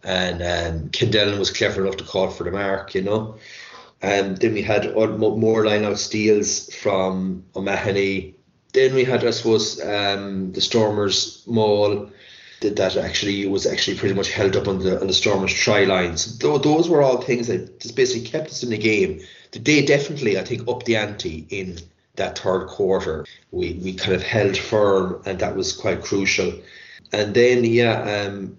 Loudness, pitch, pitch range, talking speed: -20 LUFS, 105 Hz, 95-115 Hz, 185 wpm